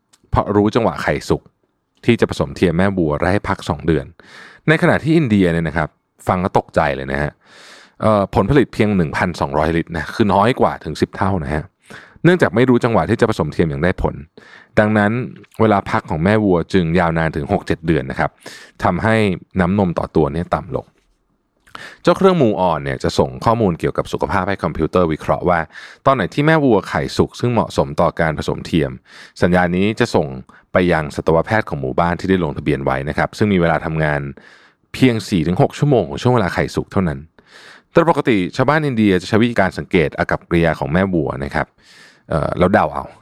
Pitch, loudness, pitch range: 95 Hz, -17 LUFS, 80-115 Hz